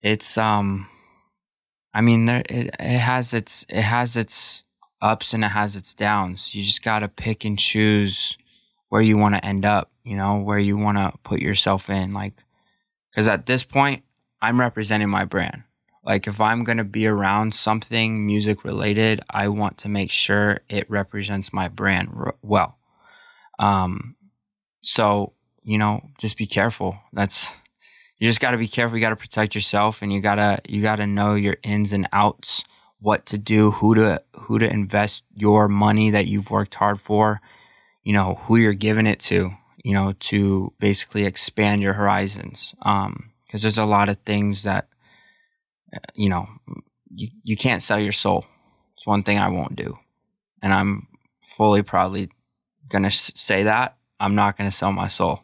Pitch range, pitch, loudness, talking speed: 100-110 Hz, 105 Hz, -21 LUFS, 180 wpm